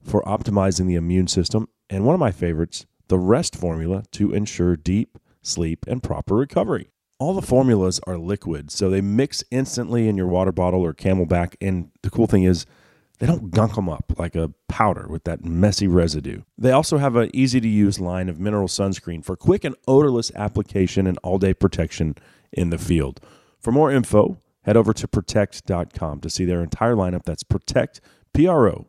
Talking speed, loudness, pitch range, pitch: 185 wpm, -21 LUFS, 85-110 Hz, 95 Hz